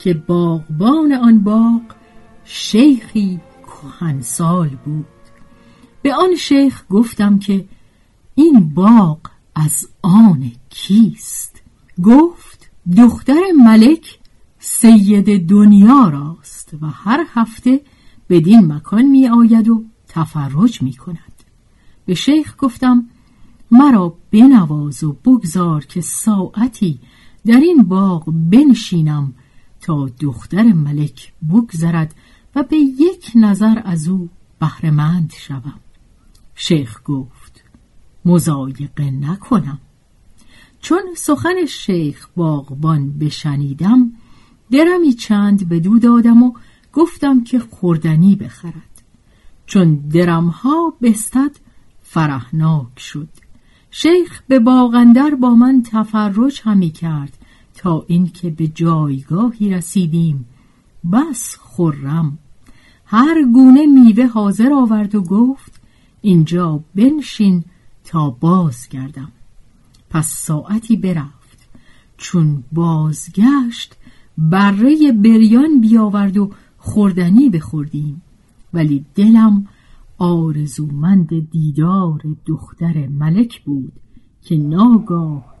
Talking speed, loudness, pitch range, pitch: 95 wpm, -13 LUFS, 150-230 Hz, 180 Hz